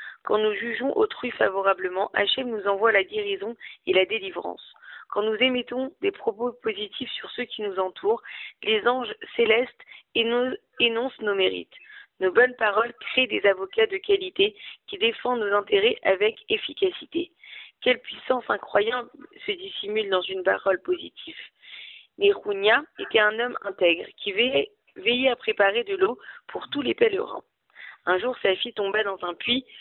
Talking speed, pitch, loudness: 155 wpm, 245 Hz, -24 LUFS